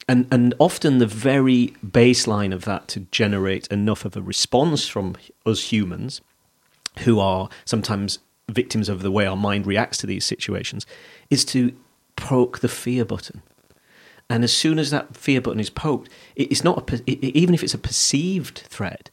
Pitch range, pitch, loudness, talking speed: 100-130 Hz, 115 Hz, -21 LUFS, 175 wpm